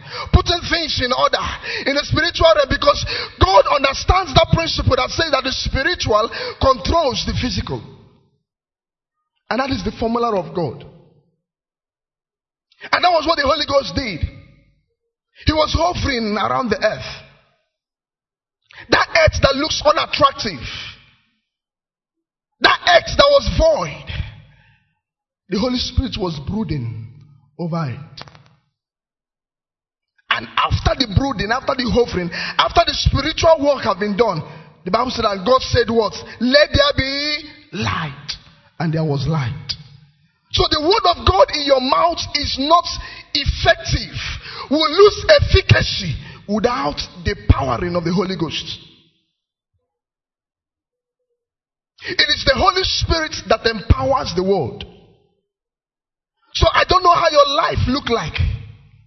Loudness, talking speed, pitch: -17 LUFS, 130 wpm, 255 Hz